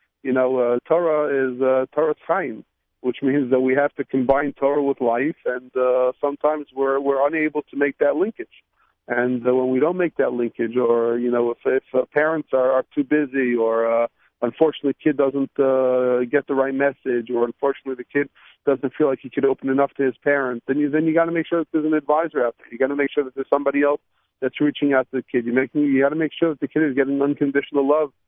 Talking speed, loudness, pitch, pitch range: 240 wpm, -21 LUFS, 140 Hz, 130-145 Hz